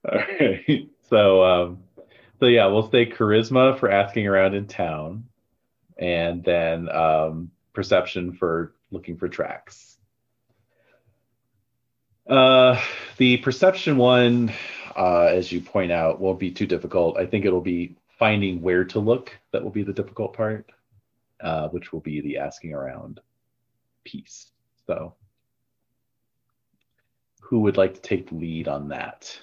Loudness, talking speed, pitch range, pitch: -21 LUFS, 135 wpm, 90-120 Hz, 105 Hz